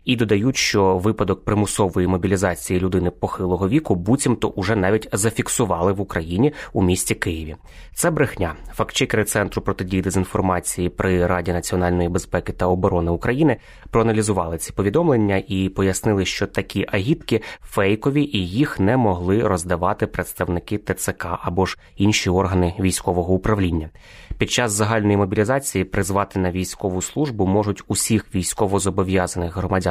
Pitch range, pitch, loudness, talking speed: 90-110 Hz, 95 Hz, -20 LUFS, 130 wpm